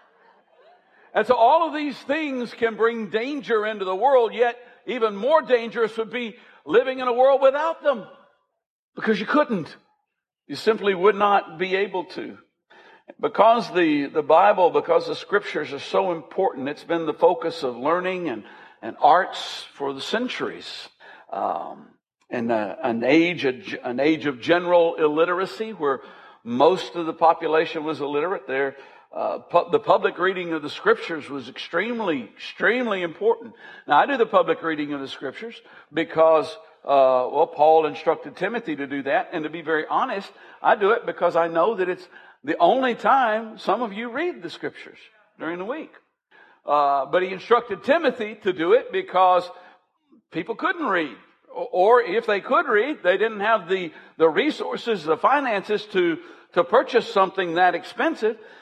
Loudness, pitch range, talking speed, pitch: -22 LUFS, 165-250 Hz, 165 wpm, 210 Hz